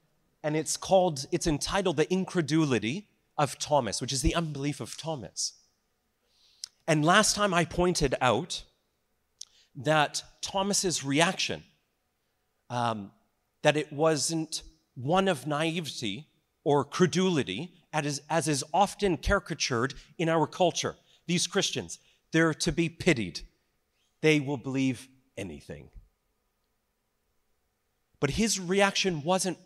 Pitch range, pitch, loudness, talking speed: 135-180 Hz, 155 Hz, -28 LUFS, 115 wpm